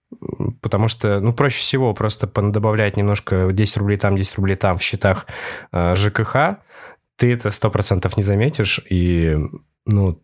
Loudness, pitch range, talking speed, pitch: -18 LUFS, 95-115 Hz, 140 wpm, 105 Hz